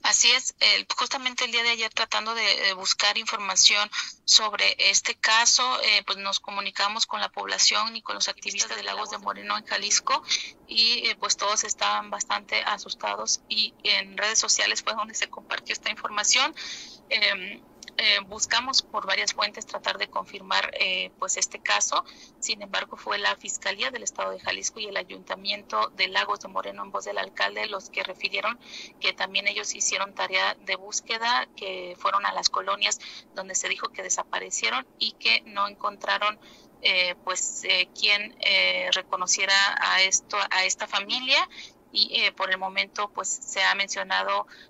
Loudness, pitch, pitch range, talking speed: -24 LUFS, 200 Hz, 185-215 Hz, 165 wpm